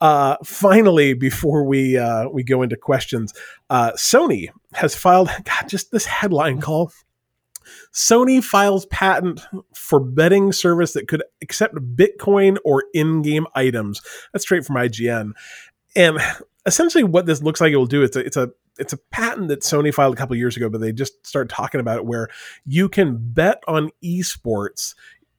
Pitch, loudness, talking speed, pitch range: 150 Hz, -18 LUFS, 170 wpm, 130-190 Hz